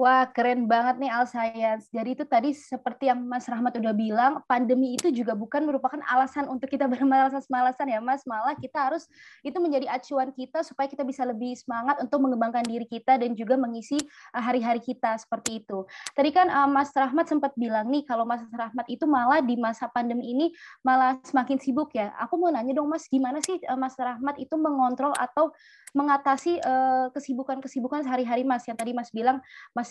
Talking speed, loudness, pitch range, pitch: 180 wpm, -26 LUFS, 240-280 Hz, 260 Hz